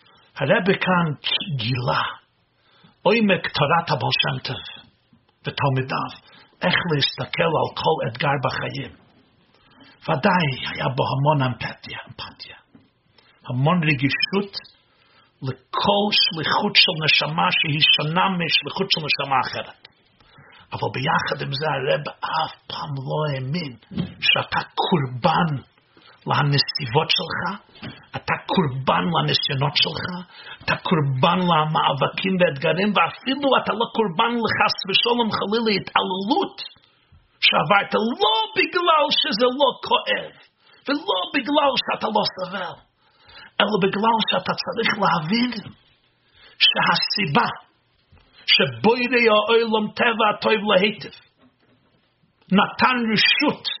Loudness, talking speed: -20 LUFS, 95 wpm